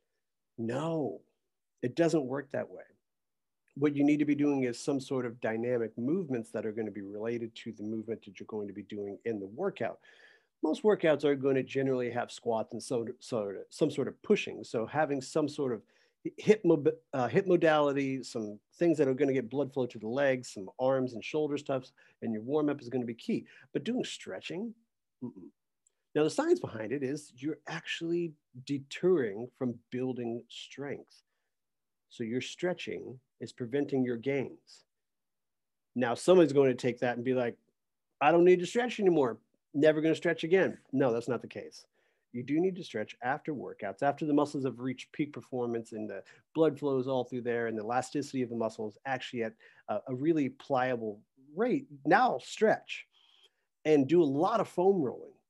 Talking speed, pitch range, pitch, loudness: 195 wpm, 120-160 Hz, 135 Hz, -32 LUFS